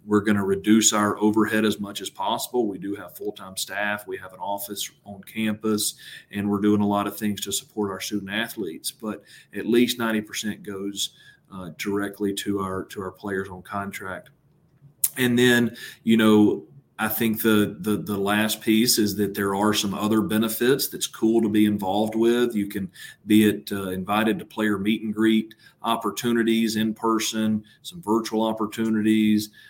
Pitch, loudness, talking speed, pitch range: 105 Hz, -23 LUFS, 180 wpm, 100-110 Hz